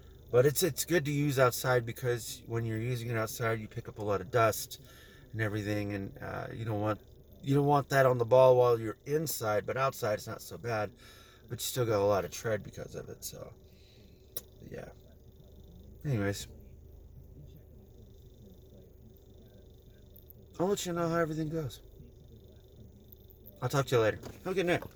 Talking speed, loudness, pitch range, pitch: 175 wpm, -31 LUFS, 105-140 Hz, 120 Hz